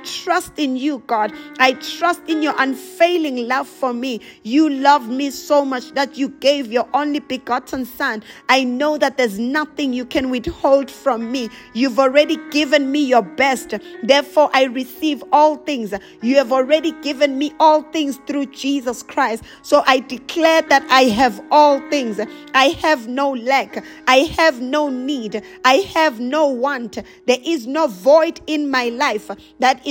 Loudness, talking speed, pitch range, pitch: -17 LUFS, 170 wpm, 255-300 Hz, 275 Hz